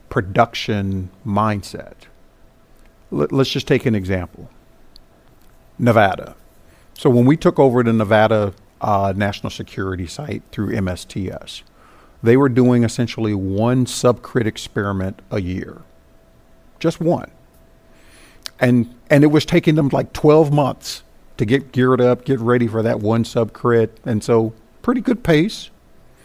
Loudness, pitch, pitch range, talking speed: -18 LUFS, 115 Hz, 100-130 Hz, 130 wpm